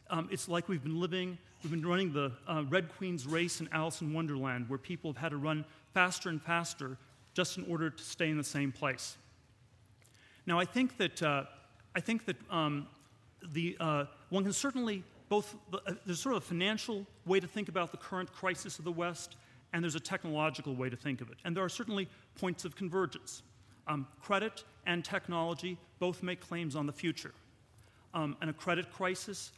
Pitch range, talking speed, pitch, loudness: 145-185 Hz, 200 wpm, 170 Hz, -36 LUFS